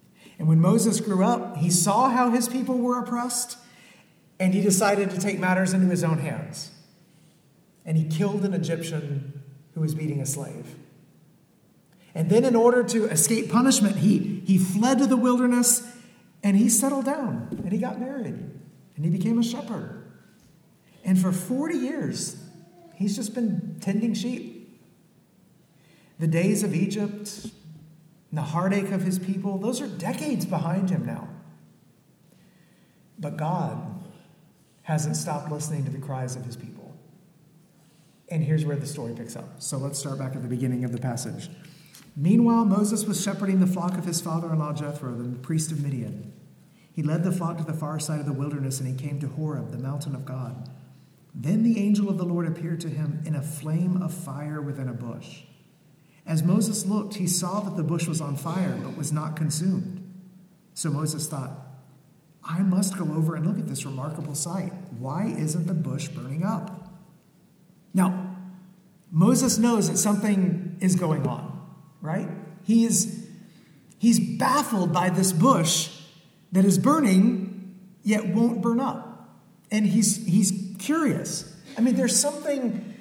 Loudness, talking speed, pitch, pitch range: -25 LUFS, 165 wpm, 180 Hz, 155-200 Hz